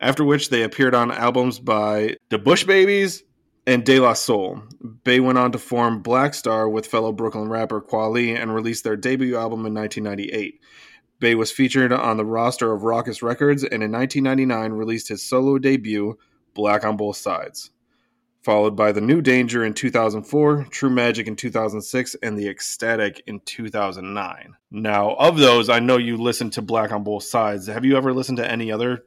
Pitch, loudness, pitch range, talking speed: 115 Hz, -20 LUFS, 110-130 Hz, 180 wpm